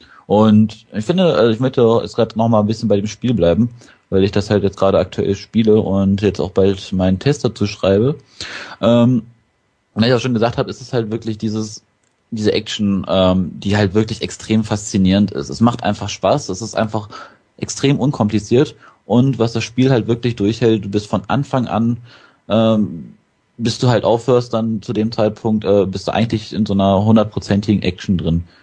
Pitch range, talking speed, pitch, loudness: 100-115 Hz, 195 wpm, 110 Hz, -16 LUFS